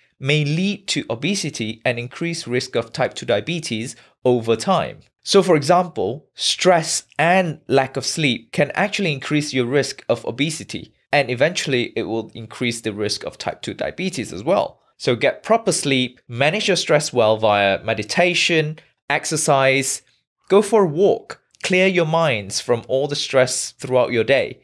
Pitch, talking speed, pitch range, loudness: 145 Hz, 160 wpm, 125-170 Hz, -19 LUFS